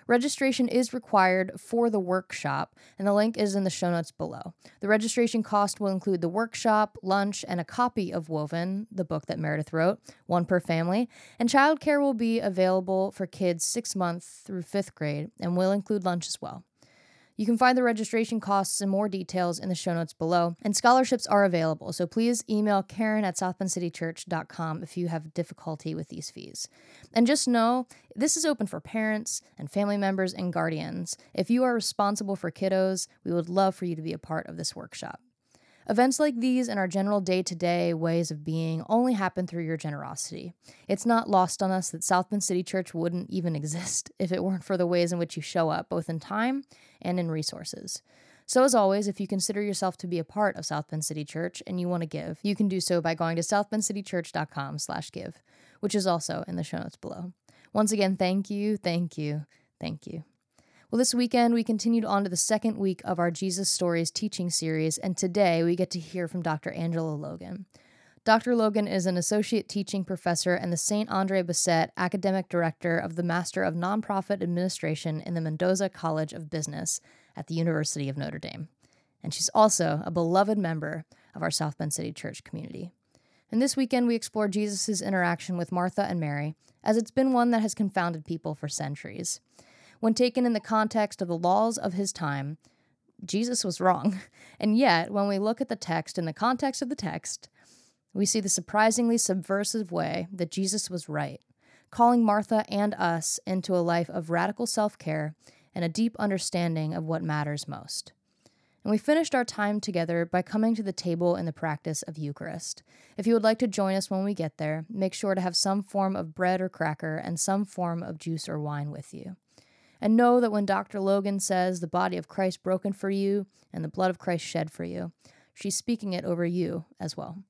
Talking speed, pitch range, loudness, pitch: 205 wpm, 170-210 Hz, -28 LUFS, 185 Hz